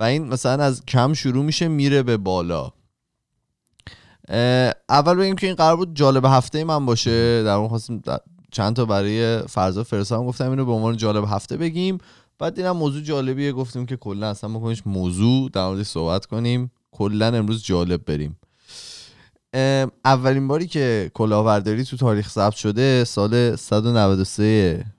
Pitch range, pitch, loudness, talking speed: 105-135 Hz, 120 Hz, -20 LUFS, 160 wpm